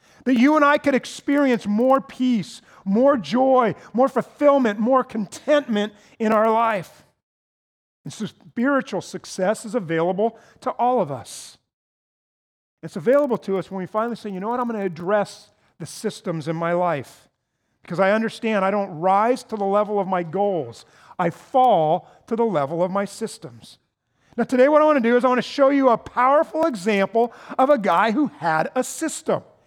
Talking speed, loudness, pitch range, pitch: 180 wpm, -21 LUFS, 195-255 Hz, 220 Hz